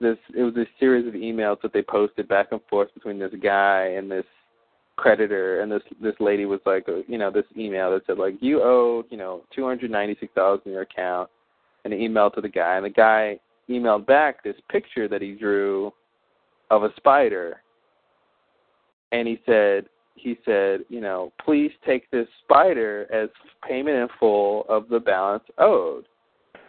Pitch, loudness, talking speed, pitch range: 105 Hz, -22 LUFS, 185 wpm, 100-120 Hz